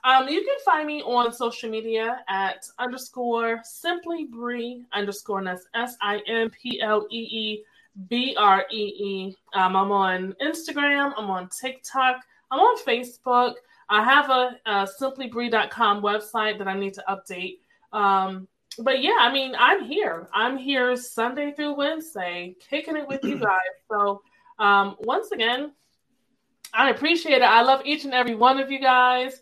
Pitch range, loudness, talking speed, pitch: 205-270 Hz, -23 LUFS, 135 wpm, 240 Hz